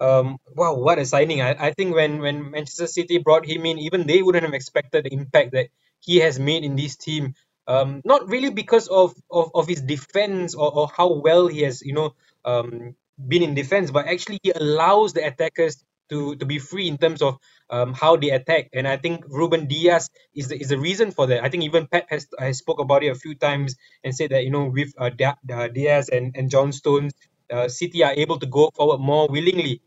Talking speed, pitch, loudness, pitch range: 225 wpm, 150 Hz, -21 LUFS, 135-170 Hz